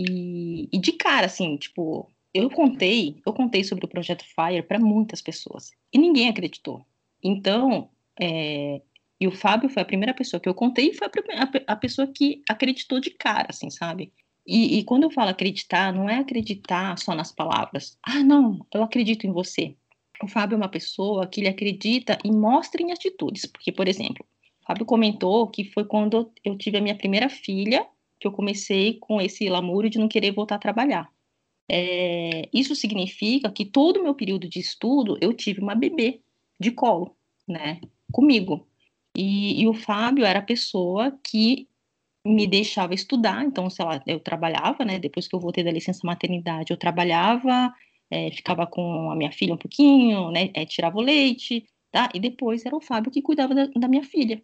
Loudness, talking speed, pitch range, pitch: -23 LUFS, 190 wpm, 180-250 Hz, 210 Hz